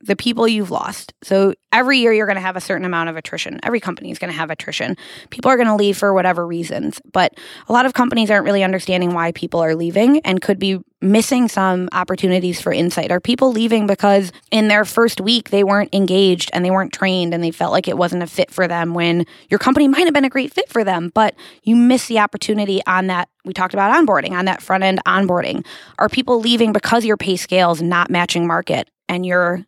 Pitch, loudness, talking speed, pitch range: 195 Hz, -16 LUFS, 235 wpm, 180-225 Hz